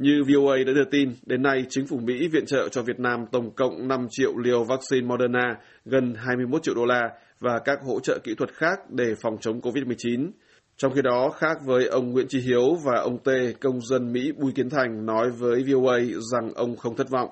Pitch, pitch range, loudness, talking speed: 125 Hz, 120-135 Hz, -24 LUFS, 220 wpm